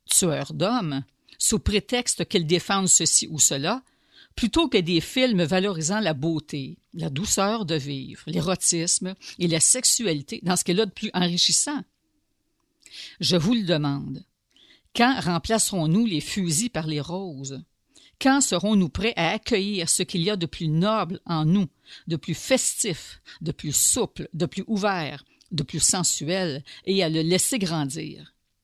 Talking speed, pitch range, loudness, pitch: 155 wpm, 160-215 Hz, -23 LUFS, 180 Hz